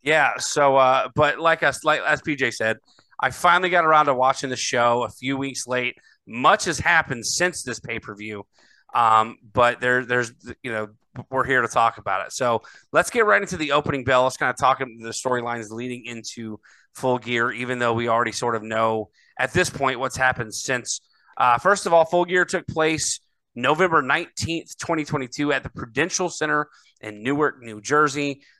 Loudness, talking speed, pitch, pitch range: -21 LUFS, 195 wpm, 130 Hz, 120-150 Hz